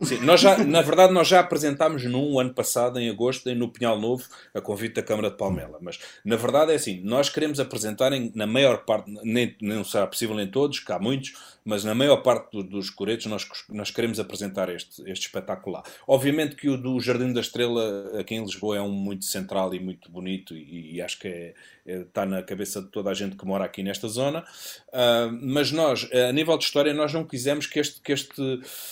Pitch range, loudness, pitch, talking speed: 100-140 Hz, -24 LUFS, 120 Hz, 225 wpm